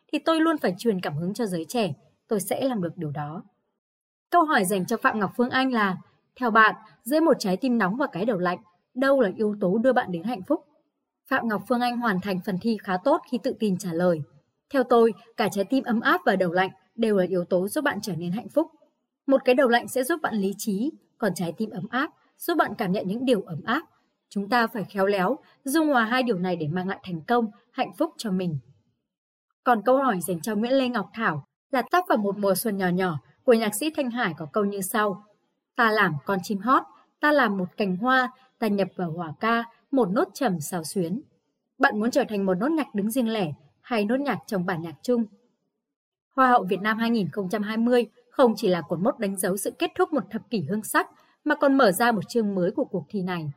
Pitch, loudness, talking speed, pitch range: 220 Hz, -25 LUFS, 240 wpm, 185-255 Hz